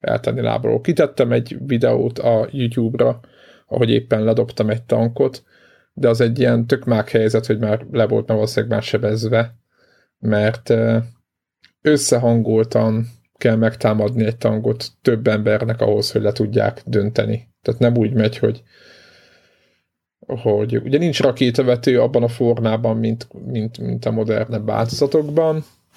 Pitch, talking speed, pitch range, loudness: 115 Hz, 130 wpm, 110-120 Hz, -18 LUFS